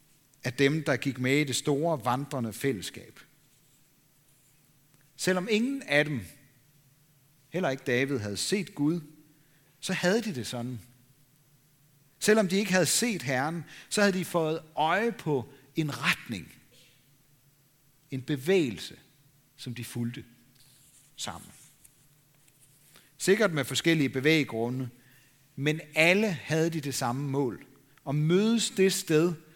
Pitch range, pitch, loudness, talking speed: 135-160 Hz, 145 Hz, -28 LUFS, 120 wpm